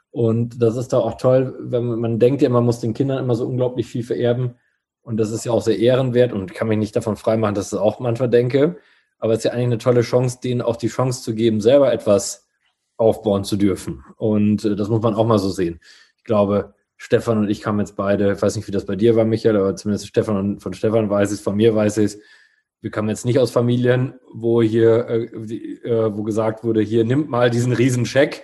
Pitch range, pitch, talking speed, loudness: 105-120 Hz, 115 Hz, 240 wpm, -19 LUFS